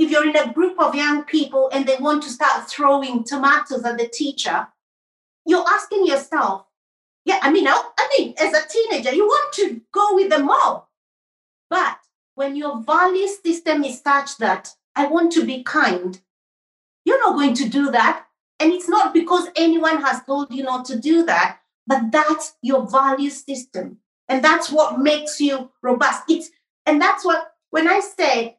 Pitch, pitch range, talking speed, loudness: 295 Hz, 270-330 Hz, 185 wpm, -19 LUFS